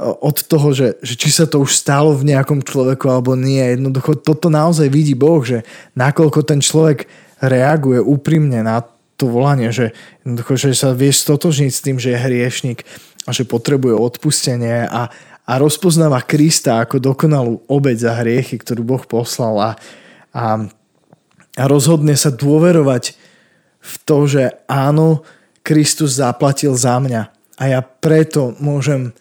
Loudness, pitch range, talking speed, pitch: -14 LUFS, 125-150 Hz, 150 wpm, 135 Hz